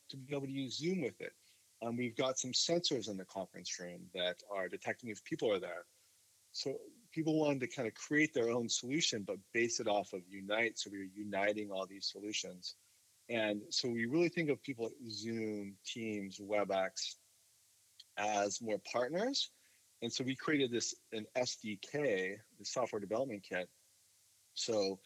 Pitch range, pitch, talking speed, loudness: 100-135 Hz, 115 Hz, 175 wpm, -38 LUFS